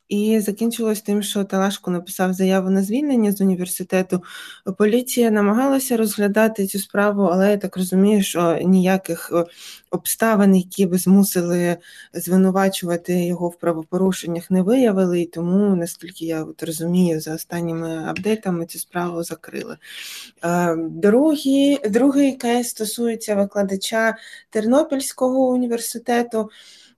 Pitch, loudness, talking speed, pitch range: 195 Hz, -20 LUFS, 110 wpm, 175-220 Hz